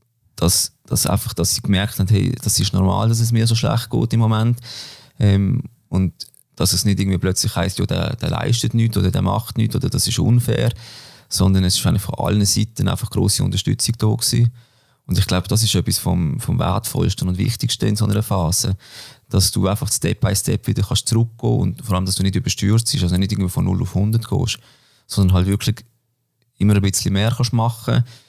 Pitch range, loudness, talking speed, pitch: 100-120 Hz, -19 LUFS, 220 wpm, 110 Hz